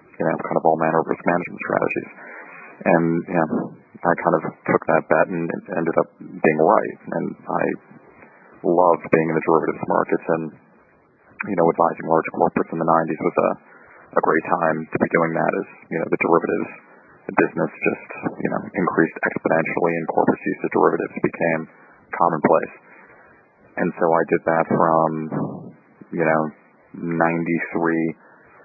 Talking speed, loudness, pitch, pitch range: 160 wpm, -21 LUFS, 80 Hz, 80-85 Hz